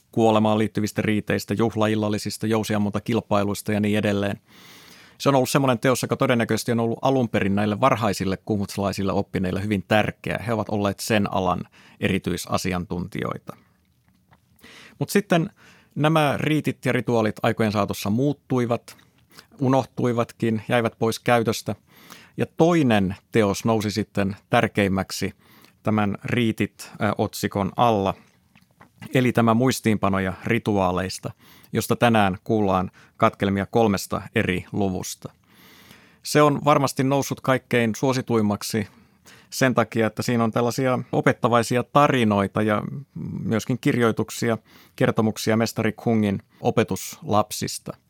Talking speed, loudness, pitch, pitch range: 105 wpm, -23 LUFS, 110 Hz, 100-125 Hz